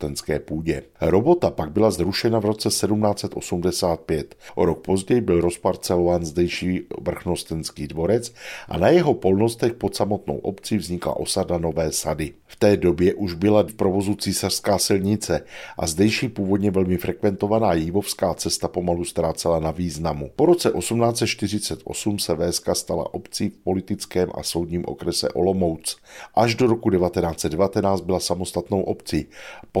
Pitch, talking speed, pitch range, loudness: 95 Hz, 135 wpm, 85-105 Hz, -22 LUFS